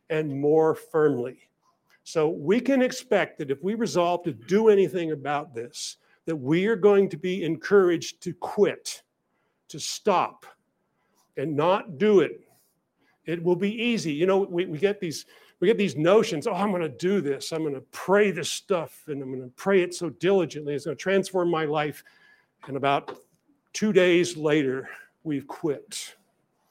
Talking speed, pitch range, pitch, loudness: 165 wpm, 155-200 Hz, 175 Hz, -25 LUFS